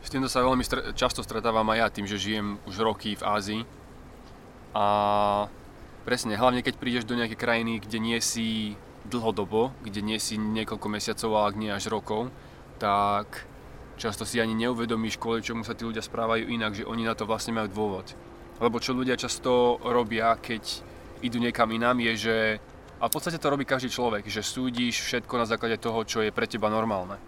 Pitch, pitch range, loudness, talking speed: 115 Hz, 105-120 Hz, -28 LUFS, 185 wpm